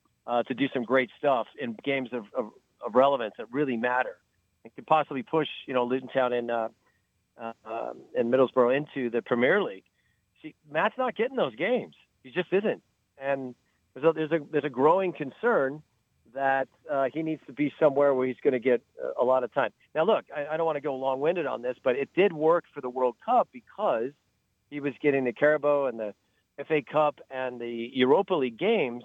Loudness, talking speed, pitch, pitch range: -27 LUFS, 210 wpm, 135 Hz, 120-150 Hz